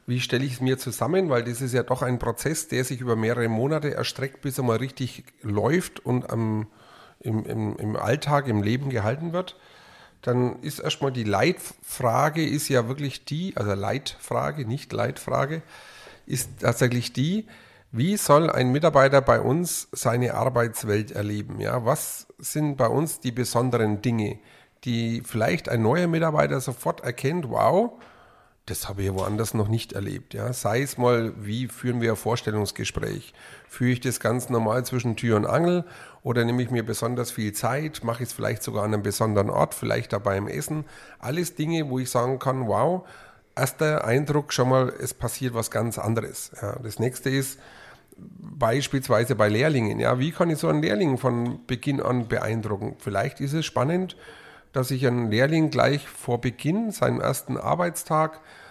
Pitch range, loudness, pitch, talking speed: 115-140 Hz, -25 LUFS, 125 Hz, 170 wpm